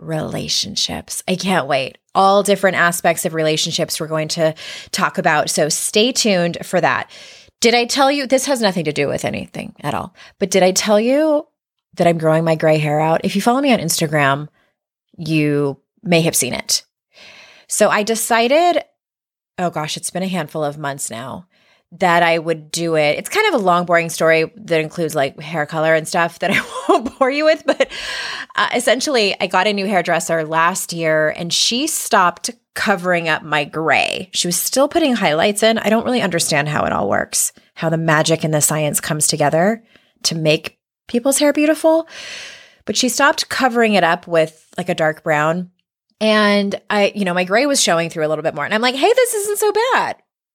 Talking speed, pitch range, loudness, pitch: 200 wpm, 160-235 Hz, -16 LUFS, 180 Hz